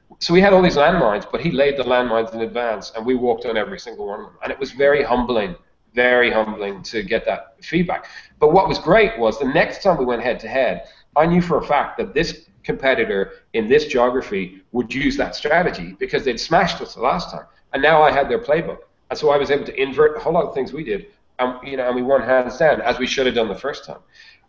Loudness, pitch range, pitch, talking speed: -19 LUFS, 125-180 Hz, 135 Hz, 255 wpm